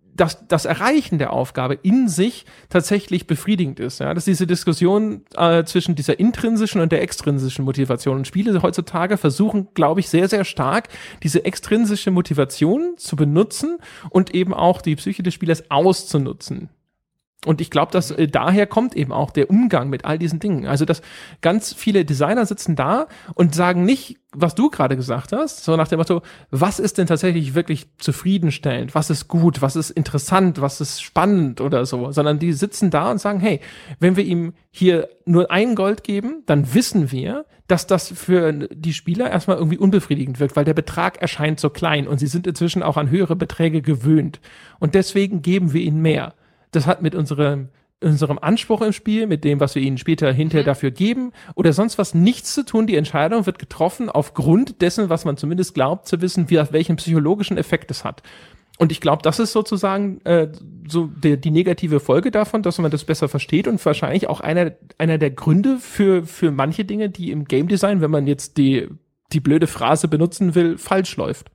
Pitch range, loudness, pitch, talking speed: 150-195 Hz, -19 LUFS, 170 Hz, 190 wpm